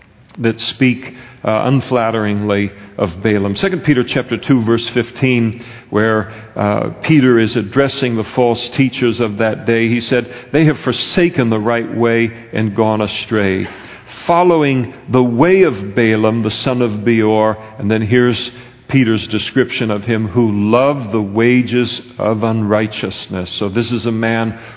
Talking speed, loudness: 150 wpm, -15 LUFS